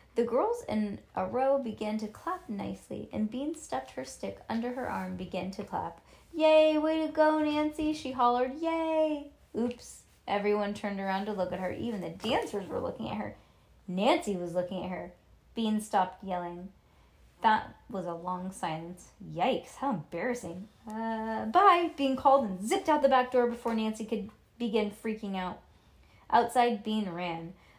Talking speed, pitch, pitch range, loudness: 170 wpm, 220 Hz, 190-275 Hz, -31 LUFS